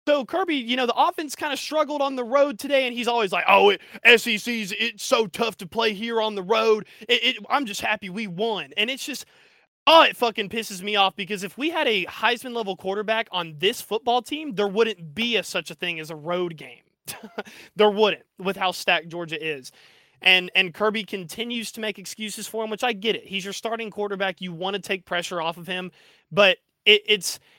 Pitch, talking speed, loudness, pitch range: 215 Hz, 220 wpm, -23 LUFS, 190-235 Hz